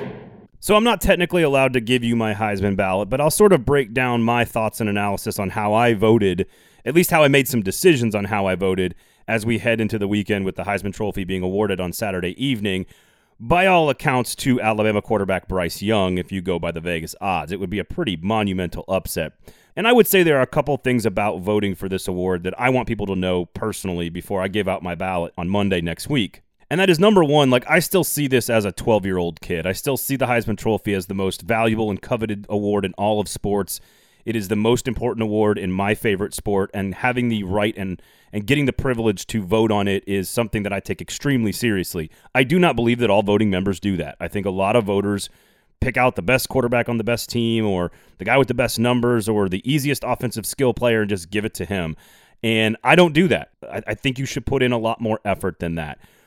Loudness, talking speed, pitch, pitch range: -20 LUFS, 245 wpm, 110 Hz, 95-125 Hz